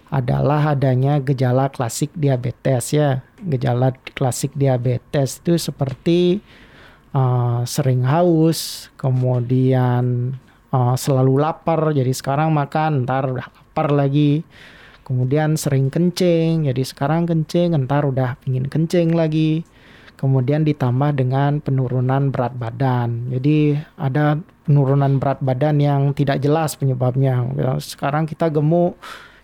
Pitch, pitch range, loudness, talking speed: 140 Hz, 130-155 Hz, -19 LUFS, 110 wpm